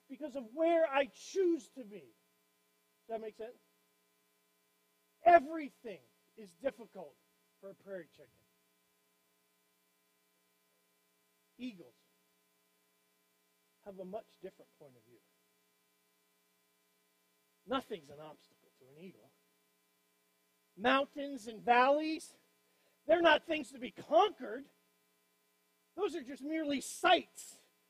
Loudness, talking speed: -33 LUFS, 100 wpm